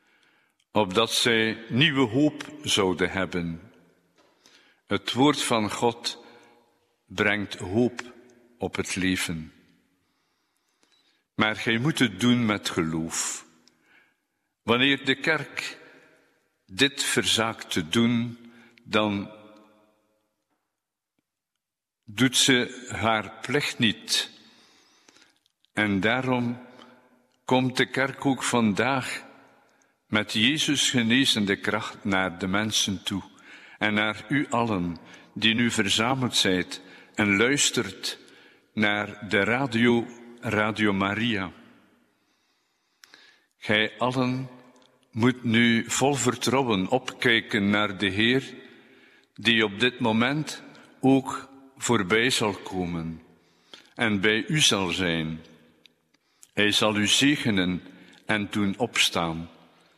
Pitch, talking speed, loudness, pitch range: 115 Hz, 95 wpm, -24 LUFS, 100-125 Hz